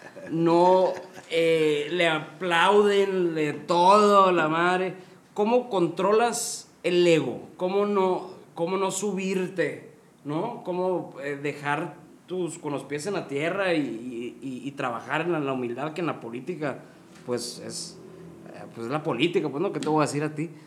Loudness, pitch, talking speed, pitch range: -25 LUFS, 170 Hz, 165 wpm, 150-185 Hz